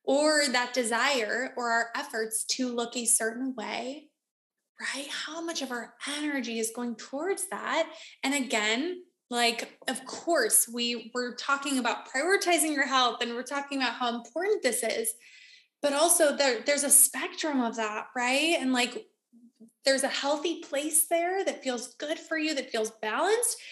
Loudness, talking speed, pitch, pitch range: -27 LUFS, 165 wpm, 270 Hz, 240-315 Hz